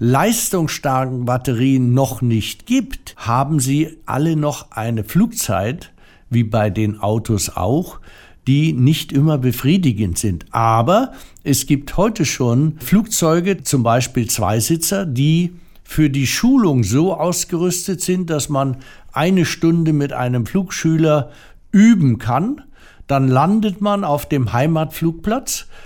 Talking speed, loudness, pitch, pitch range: 120 wpm, -17 LUFS, 145 Hz, 125-170 Hz